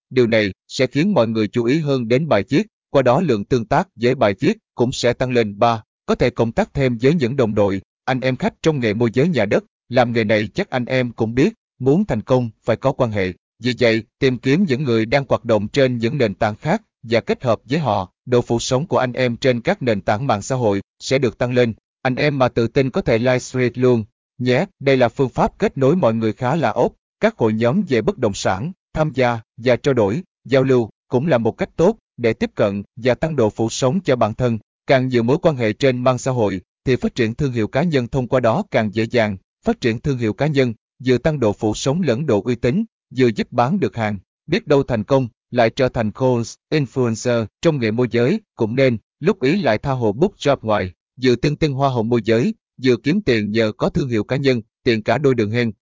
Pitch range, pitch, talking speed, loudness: 115-135 Hz, 125 Hz, 250 wpm, -19 LUFS